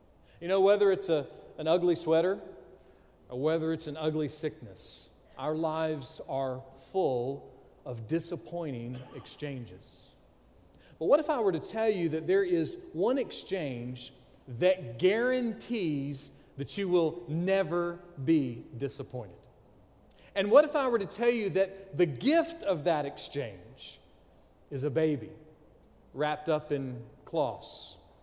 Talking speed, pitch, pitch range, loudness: 135 wpm, 155 Hz, 135-185 Hz, -30 LUFS